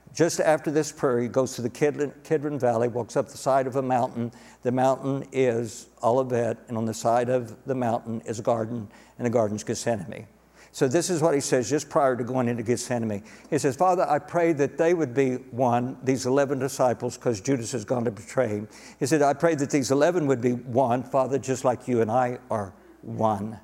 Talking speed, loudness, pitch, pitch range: 220 wpm, -25 LUFS, 130 Hz, 120-140 Hz